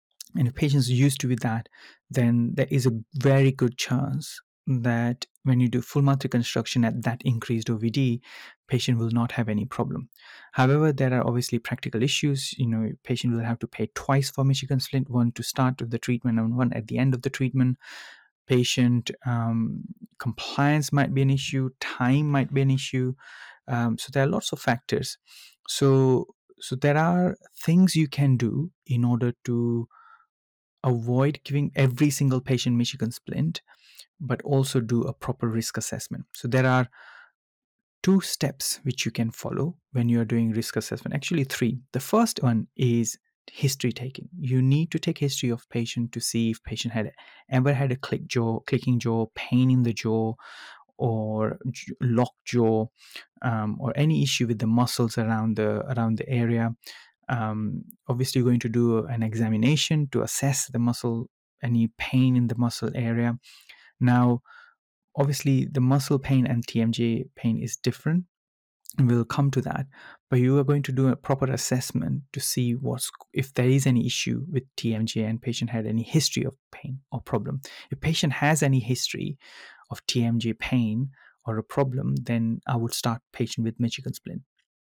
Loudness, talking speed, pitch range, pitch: -25 LUFS, 175 wpm, 115-135 Hz, 125 Hz